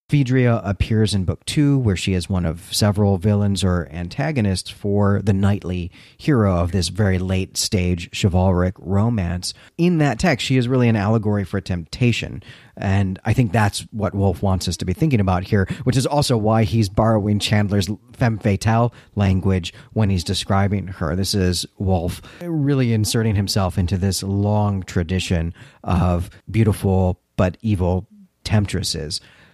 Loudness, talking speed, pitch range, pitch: -20 LUFS, 155 wpm, 95-110 Hz, 100 Hz